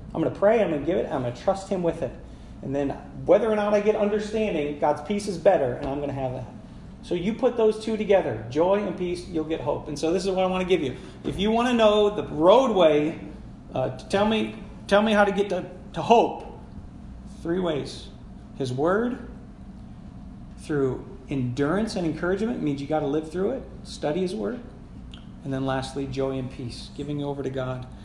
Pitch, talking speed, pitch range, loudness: 175 Hz, 210 wpm, 140-205 Hz, -25 LUFS